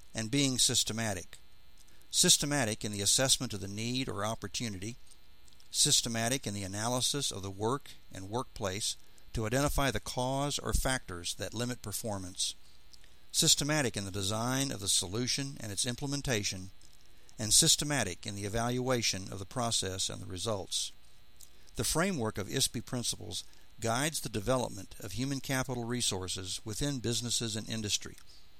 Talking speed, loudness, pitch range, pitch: 140 wpm, -31 LUFS, 100-130 Hz, 115 Hz